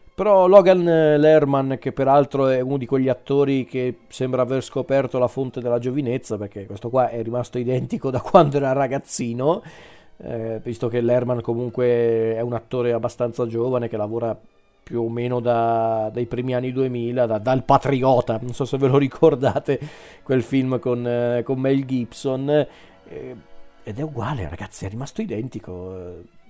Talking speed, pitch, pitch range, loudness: 160 wpm, 125 Hz, 120-135 Hz, -21 LUFS